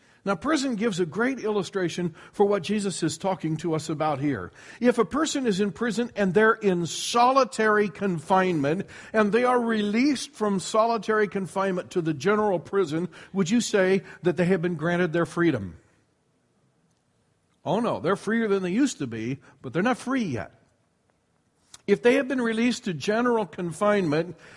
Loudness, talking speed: -25 LUFS, 170 wpm